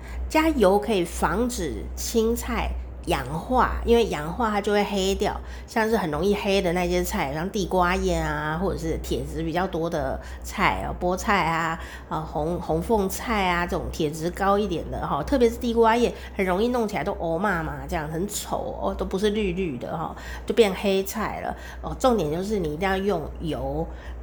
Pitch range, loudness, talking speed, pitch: 165-210 Hz, -25 LUFS, 265 characters per minute, 190 Hz